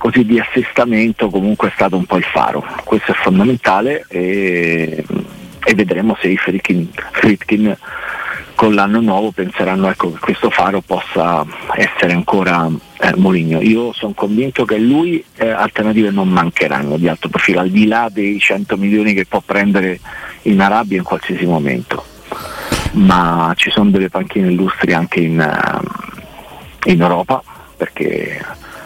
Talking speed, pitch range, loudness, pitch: 145 wpm, 90-110 Hz, -14 LUFS, 100 Hz